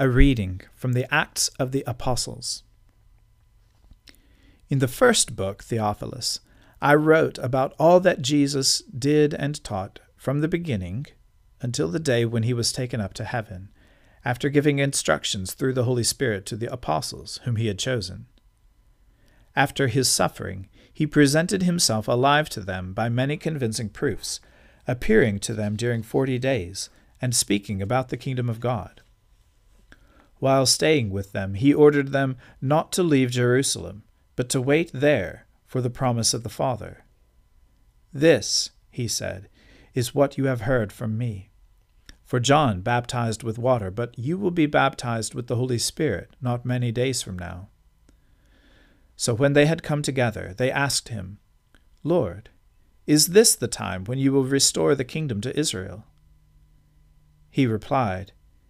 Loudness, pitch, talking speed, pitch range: -23 LUFS, 120 Hz, 150 wpm, 105-135 Hz